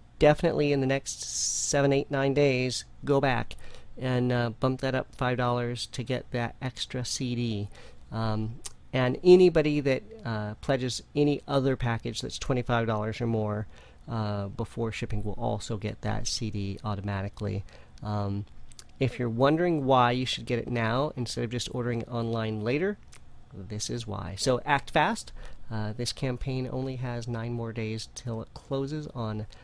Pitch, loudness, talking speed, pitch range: 120 Hz, -29 LUFS, 155 wpm, 110-130 Hz